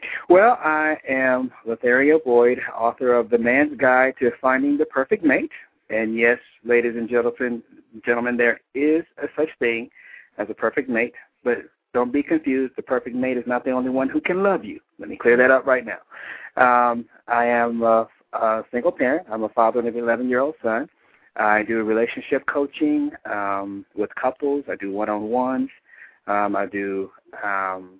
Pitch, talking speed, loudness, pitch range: 125 Hz, 185 wpm, -21 LUFS, 115-140 Hz